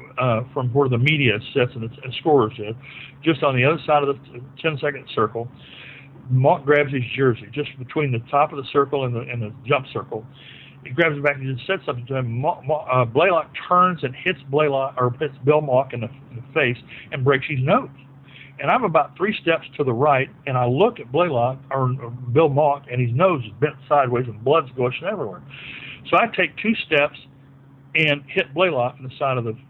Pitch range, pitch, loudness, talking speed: 125-150 Hz, 135 Hz, -21 LUFS, 220 wpm